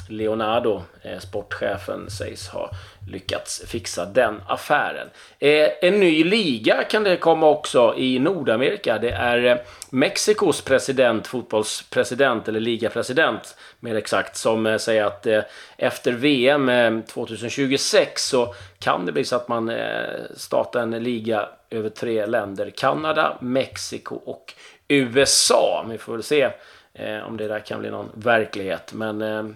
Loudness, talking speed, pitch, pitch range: -21 LUFS, 140 wpm, 115 Hz, 110-135 Hz